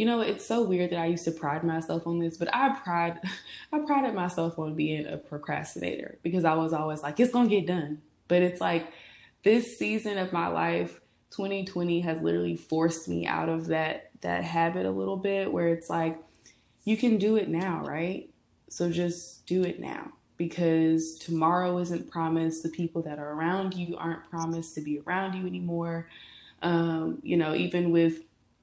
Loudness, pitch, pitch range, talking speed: -29 LUFS, 165 Hz, 160-180 Hz, 185 wpm